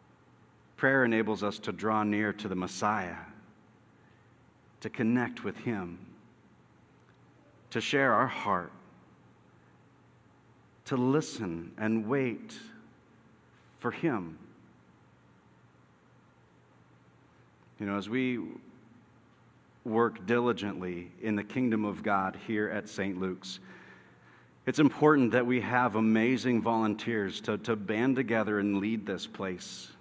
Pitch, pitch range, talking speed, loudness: 110 Hz, 100-120 Hz, 105 wpm, -30 LUFS